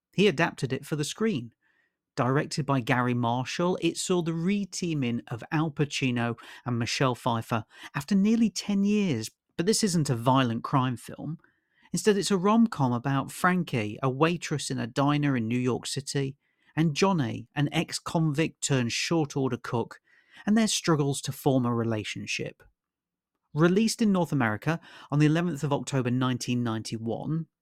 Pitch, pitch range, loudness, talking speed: 145 Hz, 125-175 Hz, -27 LUFS, 160 wpm